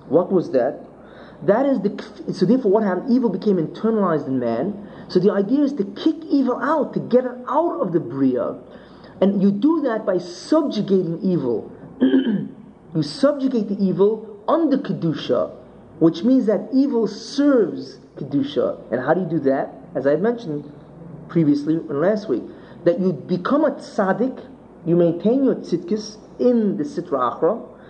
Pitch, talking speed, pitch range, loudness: 205 Hz, 165 wpm, 175-245 Hz, -20 LUFS